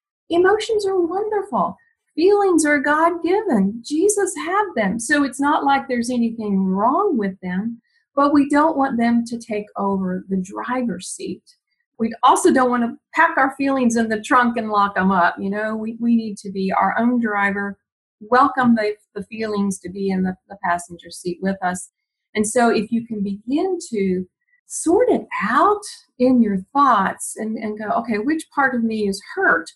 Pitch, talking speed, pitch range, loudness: 235 Hz, 185 wpm, 205-315 Hz, -19 LUFS